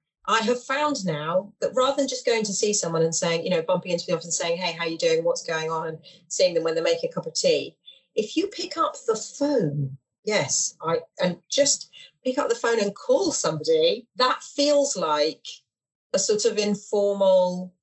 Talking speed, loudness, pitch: 215 wpm, -24 LUFS, 220 Hz